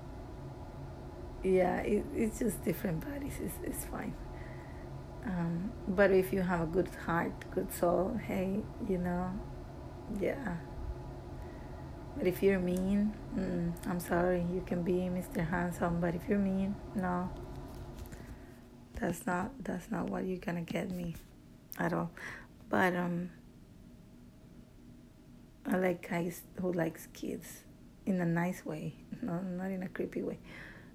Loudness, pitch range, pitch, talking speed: -35 LUFS, 175-190 Hz, 180 Hz, 135 wpm